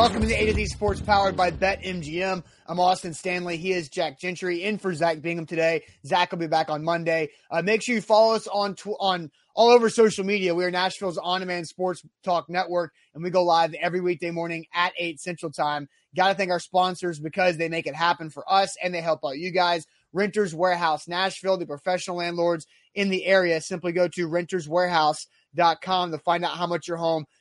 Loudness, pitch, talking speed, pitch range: -24 LUFS, 175 Hz, 215 wpm, 165-185 Hz